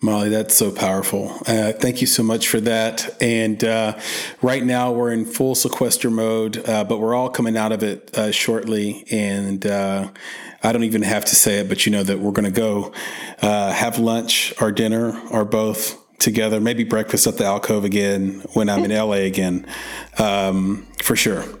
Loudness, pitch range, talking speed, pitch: -19 LUFS, 105-115 Hz, 190 wpm, 110 Hz